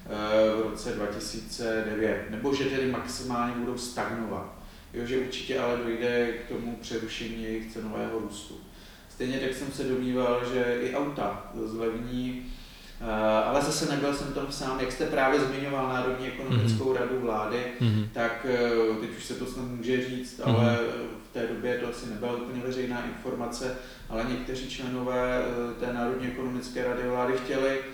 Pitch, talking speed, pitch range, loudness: 120 Hz, 150 wpm, 115-130 Hz, -30 LUFS